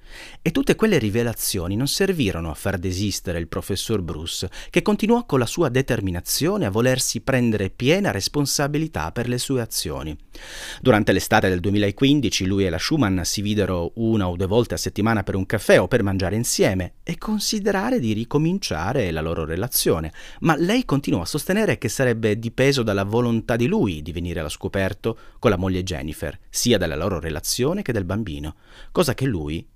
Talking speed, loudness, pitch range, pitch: 175 wpm, -22 LUFS, 95-135 Hz, 110 Hz